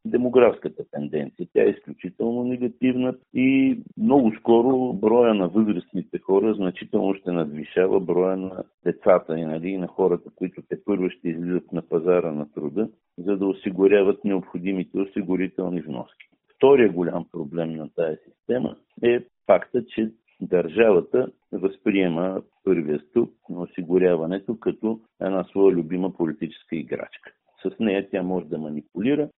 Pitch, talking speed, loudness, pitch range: 95 Hz, 130 wpm, -23 LUFS, 85-115 Hz